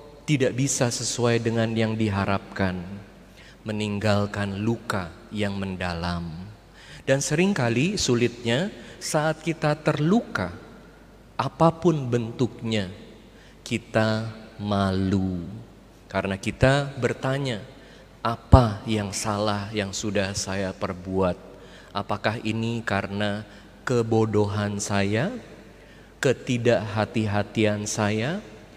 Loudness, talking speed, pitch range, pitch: -25 LUFS, 75 wpm, 100-120 Hz, 110 Hz